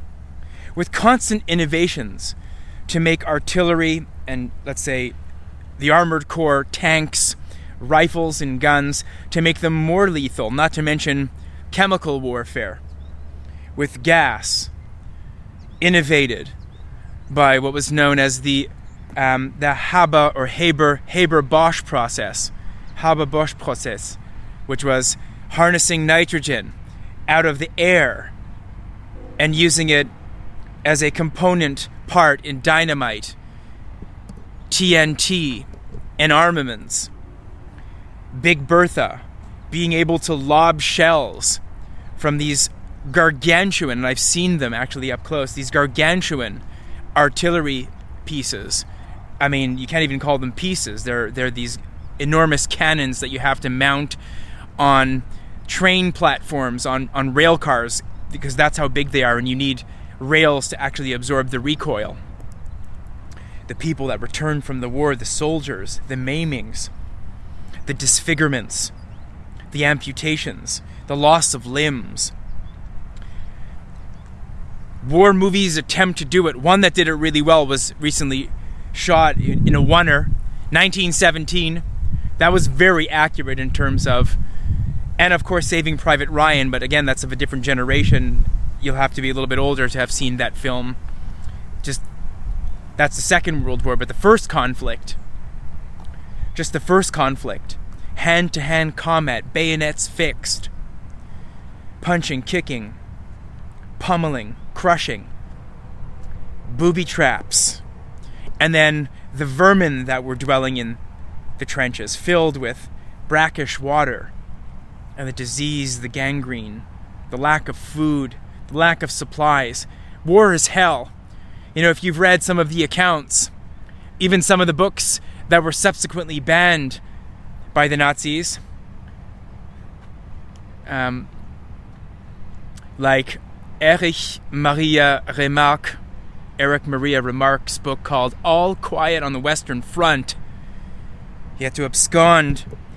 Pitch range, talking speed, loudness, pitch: 100-155 Hz, 125 wpm, -18 LUFS, 135 Hz